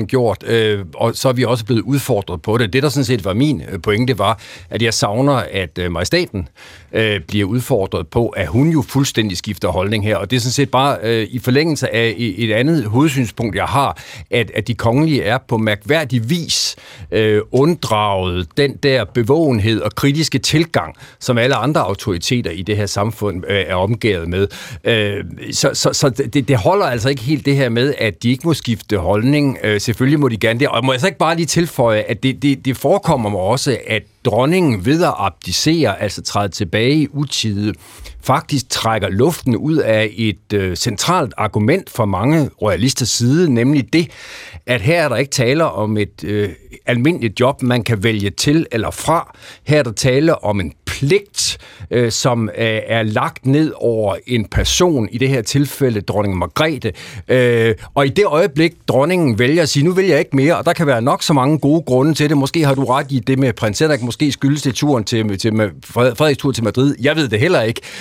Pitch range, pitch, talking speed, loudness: 105-140 Hz, 125 Hz, 205 wpm, -16 LUFS